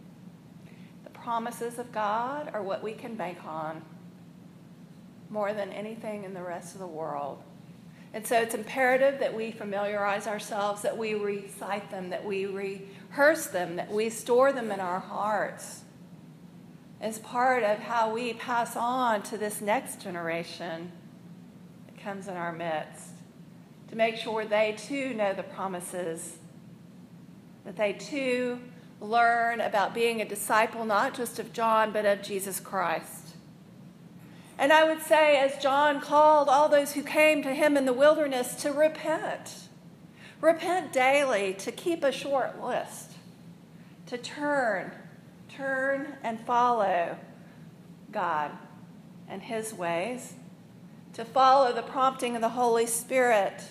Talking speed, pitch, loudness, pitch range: 135 wpm, 210 Hz, -28 LUFS, 180-245 Hz